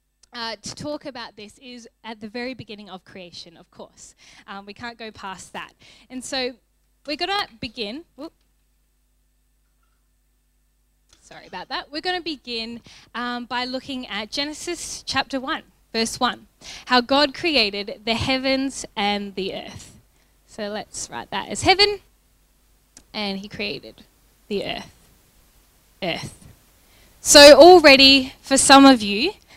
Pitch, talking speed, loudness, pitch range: 250 Hz, 140 wpm, -17 LUFS, 220-285 Hz